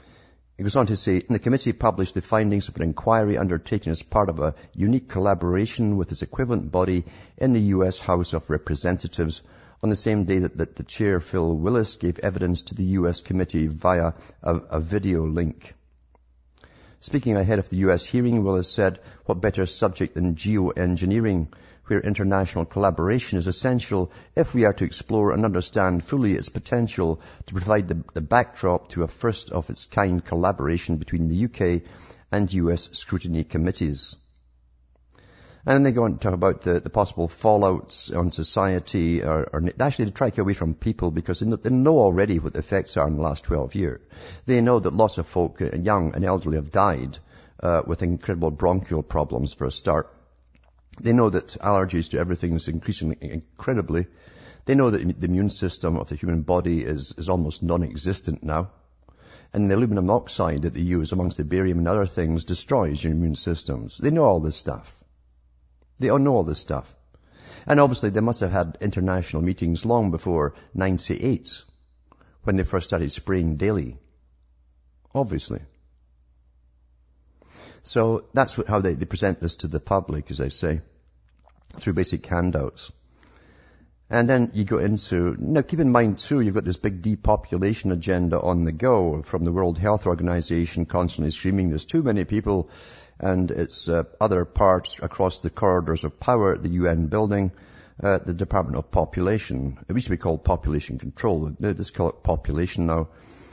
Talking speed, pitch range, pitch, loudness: 175 wpm, 80-100 Hz, 90 Hz, -23 LUFS